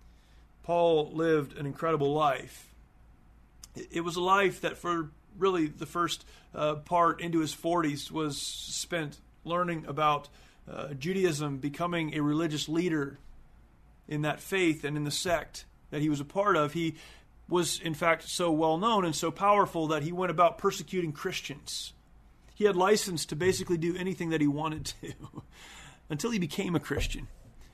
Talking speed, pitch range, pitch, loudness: 160 wpm, 150-175 Hz, 165 Hz, -30 LUFS